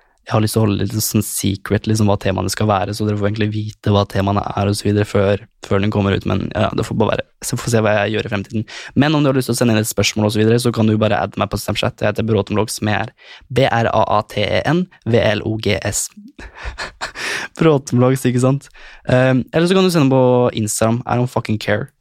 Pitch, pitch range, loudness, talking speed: 110 Hz, 105-125 Hz, -17 LUFS, 235 wpm